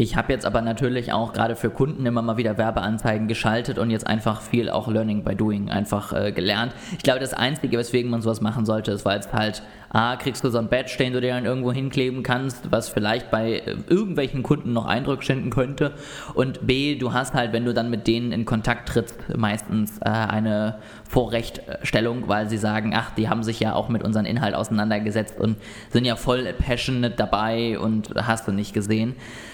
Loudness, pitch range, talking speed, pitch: -24 LUFS, 110-125 Hz, 205 wpm, 115 Hz